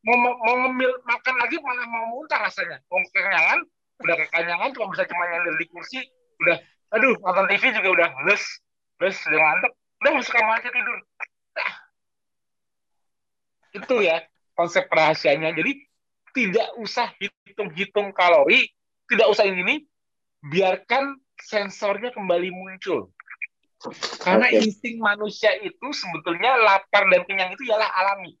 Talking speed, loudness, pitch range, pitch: 135 wpm, -21 LUFS, 185-245 Hz, 205 Hz